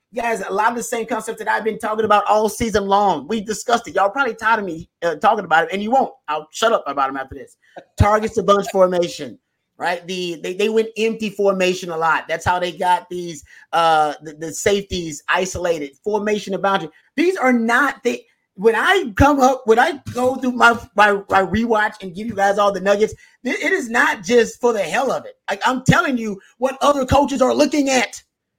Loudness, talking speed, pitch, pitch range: -18 LUFS, 225 wpm, 215 Hz, 185-240 Hz